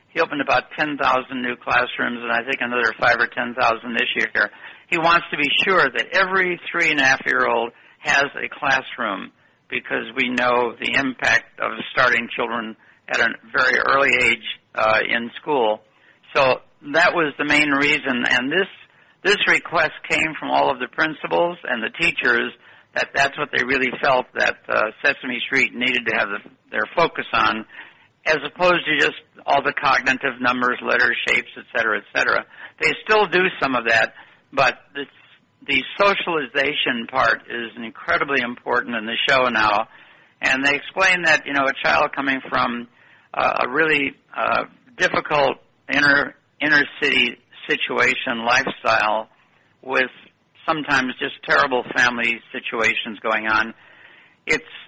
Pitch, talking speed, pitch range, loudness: 135 Hz, 155 wpm, 120-150 Hz, -19 LUFS